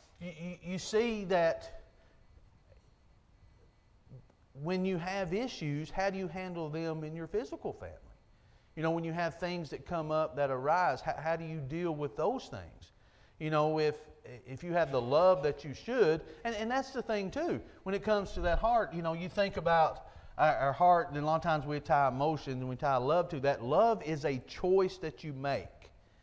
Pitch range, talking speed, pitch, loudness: 140-185 Hz, 200 wpm, 160 Hz, -33 LUFS